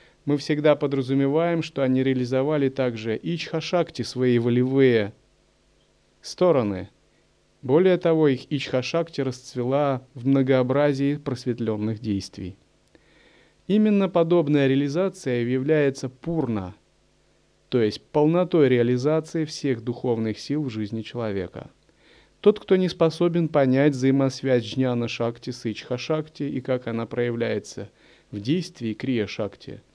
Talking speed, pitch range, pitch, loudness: 105 wpm, 120-155 Hz, 135 Hz, -23 LUFS